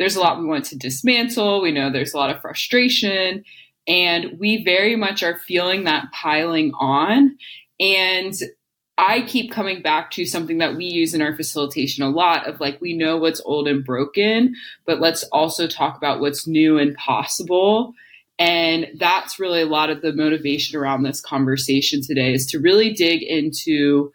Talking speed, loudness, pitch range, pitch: 180 wpm, -19 LUFS, 145-195 Hz, 165 Hz